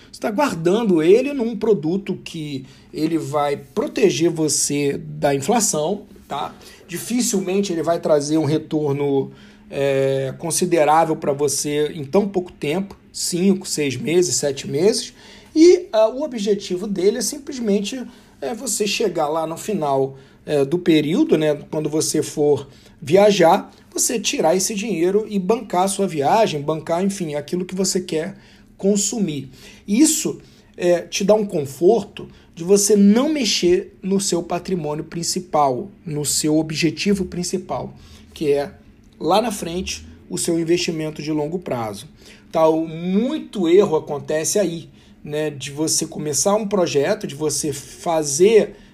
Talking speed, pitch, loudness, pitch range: 135 wpm, 170 Hz, -19 LUFS, 150-200 Hz